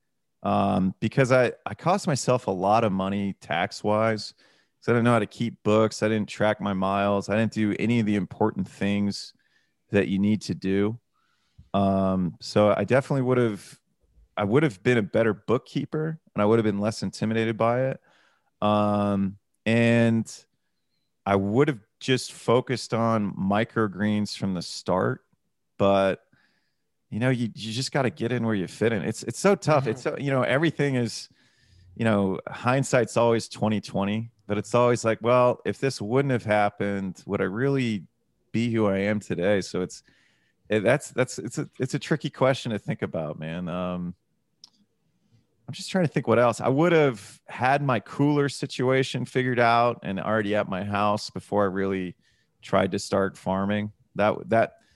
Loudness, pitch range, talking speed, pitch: -25 LUFS, 100-125 Hz, 180 wpm, 110 Hz